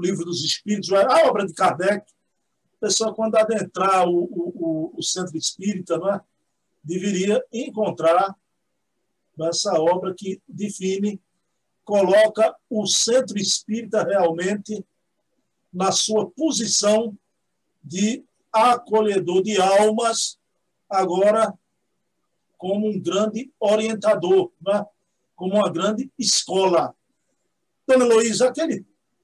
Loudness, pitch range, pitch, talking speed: -21 LUFS, 185-220 Hz, 200 Hz, 105 wpm